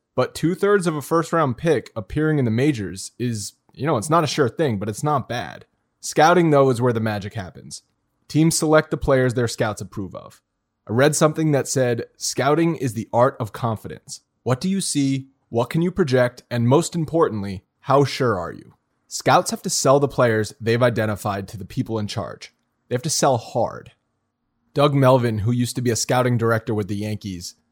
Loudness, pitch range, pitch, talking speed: -21 LUFS, 115-150 Hz, 125 Hz, 205 wpm